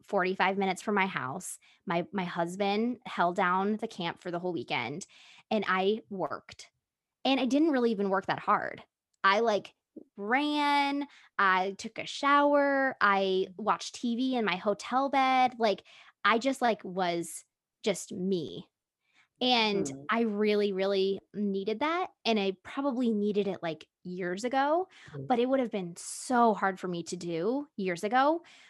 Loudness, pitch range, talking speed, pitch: -29 LUFS, 190-255 Hz, 155 wpm, 205 Hz